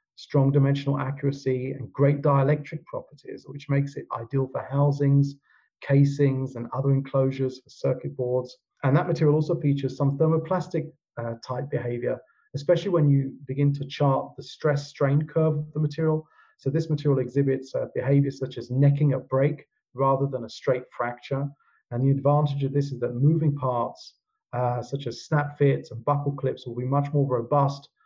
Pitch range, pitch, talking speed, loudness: 130-145 Hz, 140 Hz, 175 wpm, -25 LUFS